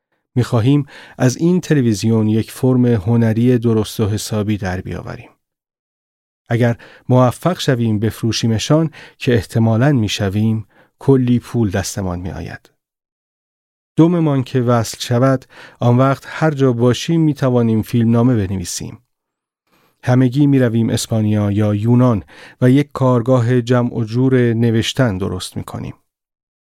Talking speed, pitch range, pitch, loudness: 120 wpm, 110-130 Hz, 120 Hz, -16 LUFS